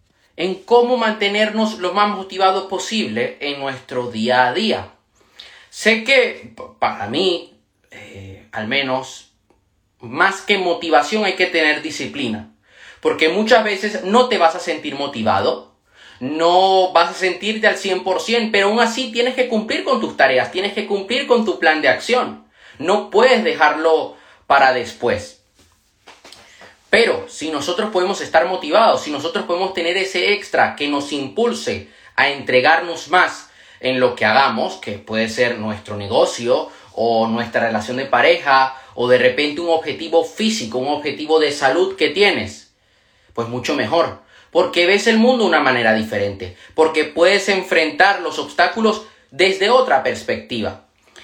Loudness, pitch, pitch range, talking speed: -17 LUFS, 170 Hz, 130-210 Hz, 150 wpm